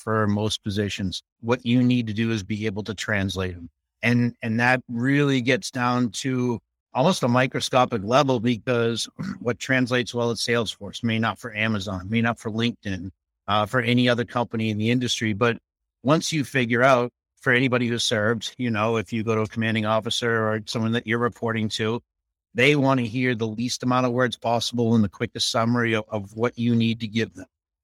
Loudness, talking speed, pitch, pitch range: -23 LUFS, 200 wpm, 115 Hz, 110-125 Hz